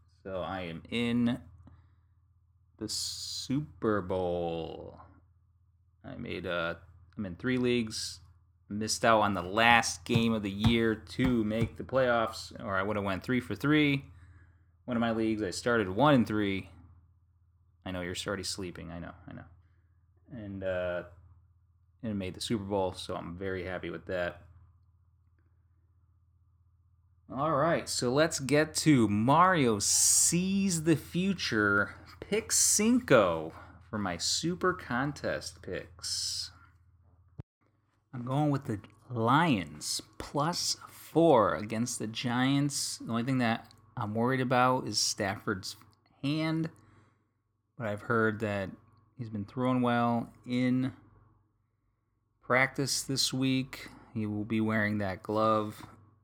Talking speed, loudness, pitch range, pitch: 130 wpm, -30 LUFS, 90-120 Hz, 105 Hz